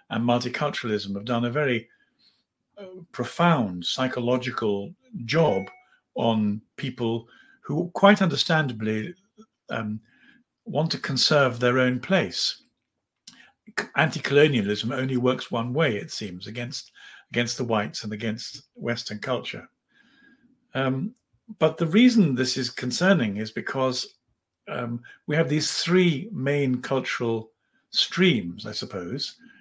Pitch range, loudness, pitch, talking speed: 120-170 Hz, -25 LUFS, 130 Hz, 115 wpm